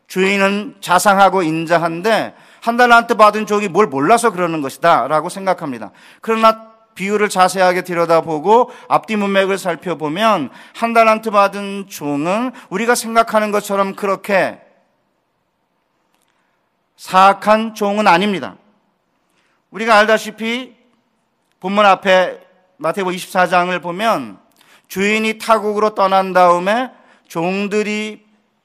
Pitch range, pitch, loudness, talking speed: 180-220 Hz, 200 Hz, -15 LUFS, 260 characters per minute